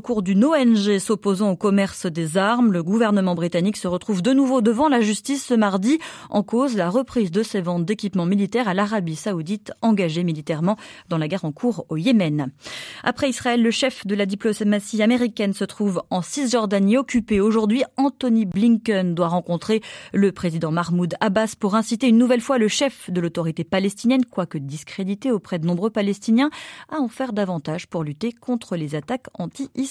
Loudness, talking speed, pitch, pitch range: -21 LUFS, 185 wpm, 210 Hz, 180-240 Hz